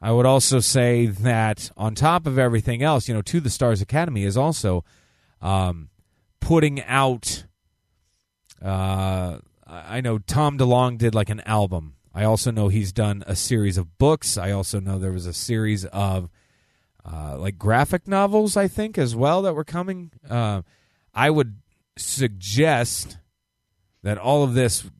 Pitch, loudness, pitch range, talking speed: 110 Hz, -22 LUFS, 95-130 Hz, 160 wpm